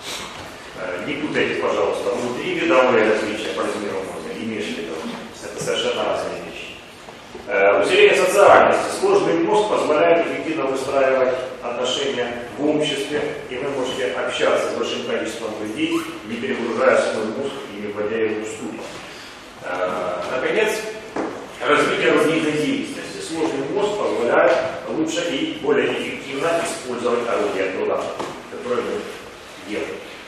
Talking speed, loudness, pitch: 120 wpm, -20 LUFS, 165 Hz